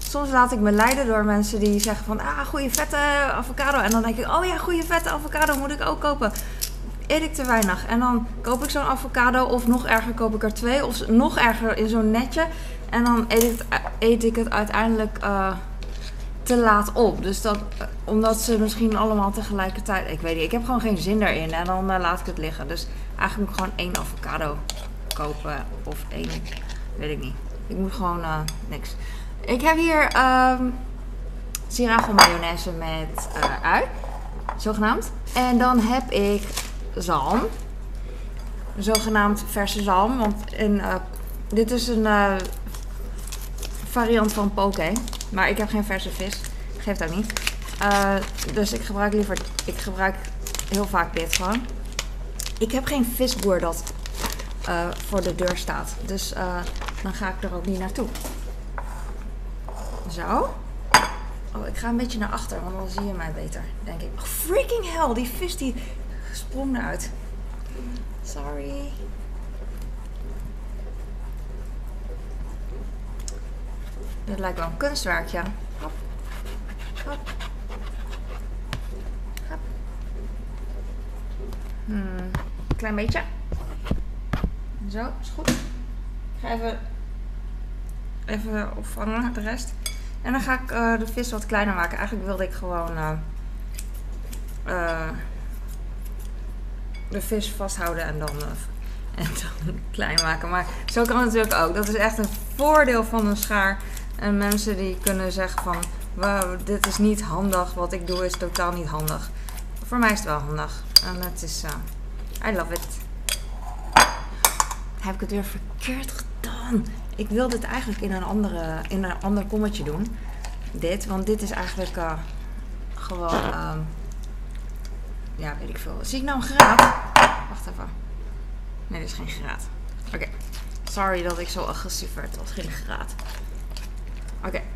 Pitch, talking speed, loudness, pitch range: 205 Hz, 150 wpm, -24 LUFS, 175-230 Hz